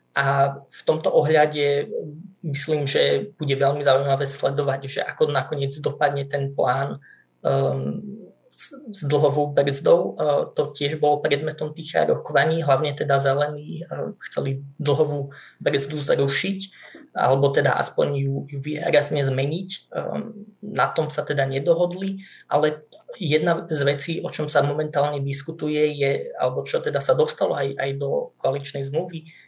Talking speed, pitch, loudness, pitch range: 140 wpm, 145 Hz, -22 LUFS, 140-160 Hz